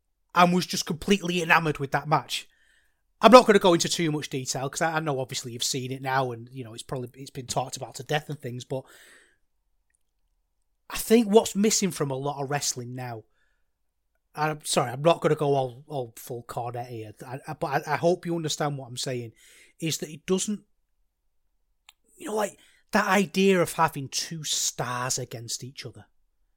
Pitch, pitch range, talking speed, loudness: 135 Hz, 125-165 Hz, 195 wpm, -25 LUFS